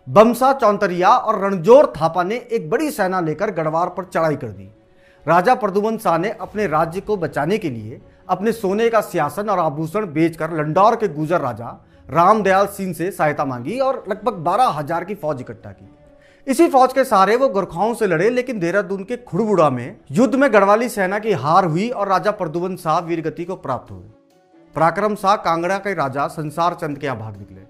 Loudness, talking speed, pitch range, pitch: -18 LUFS, 185 wpm, 155-210 Hz, 185 Hz